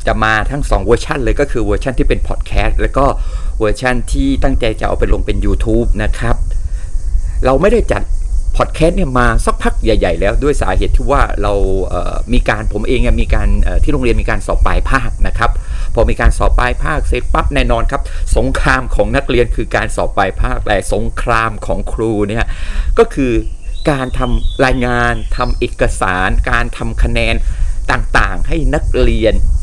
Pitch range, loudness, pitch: 95-125 Hz, -15 LUFS, 110 Hz